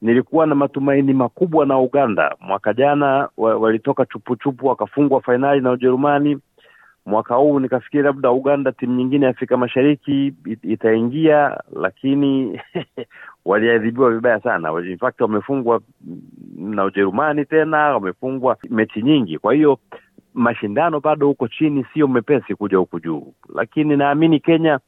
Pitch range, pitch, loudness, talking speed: 115-145 Hz, 130 Hz, -18 LUFS, 130 wpm